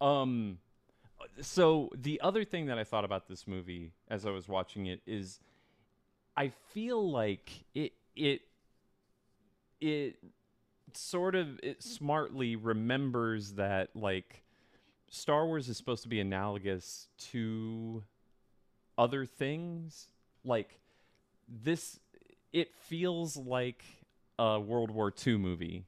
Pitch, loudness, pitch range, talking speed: 120 Hz, -35 LUFS, 105-150 Hz, 115 wpm